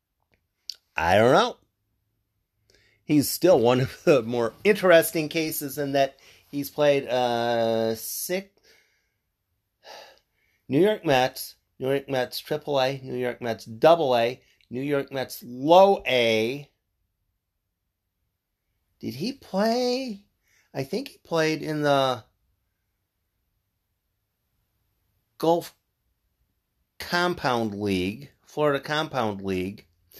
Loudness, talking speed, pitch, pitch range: -24 LUFS, 95 wpm, 120 Hz, 100-145 Hz